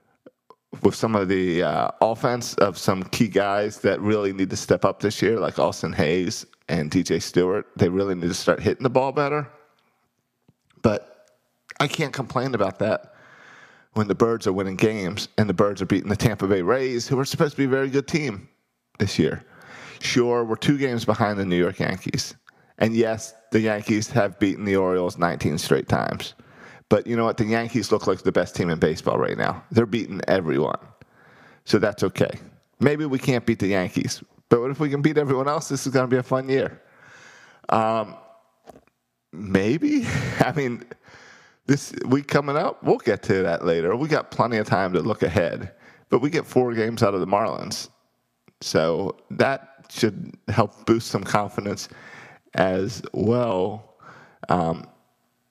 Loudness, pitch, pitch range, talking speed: -23 LUFS, 115 Hz, 100-135 Hz, 180 wpm